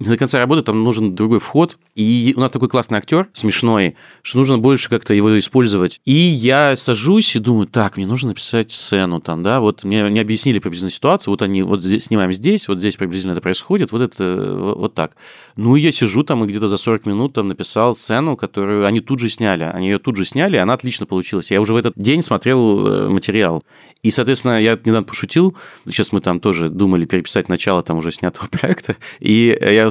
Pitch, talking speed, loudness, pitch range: 110 Hz, 210 wpm, -16 LUFS, 100-130 Hz